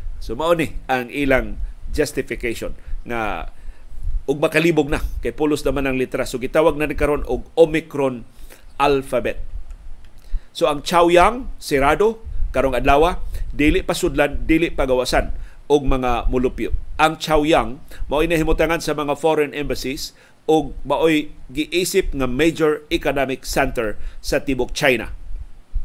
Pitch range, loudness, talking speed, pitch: 125-155 Hz, -20 LUFS, 130 wpm, 140 Hz